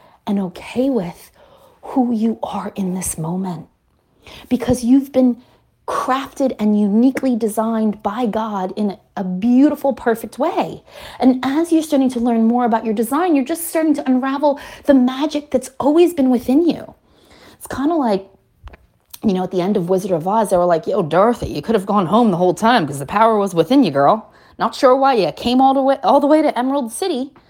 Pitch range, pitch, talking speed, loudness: 210-275 Hz, 245 Hz, 200 wpm, -17 LUFS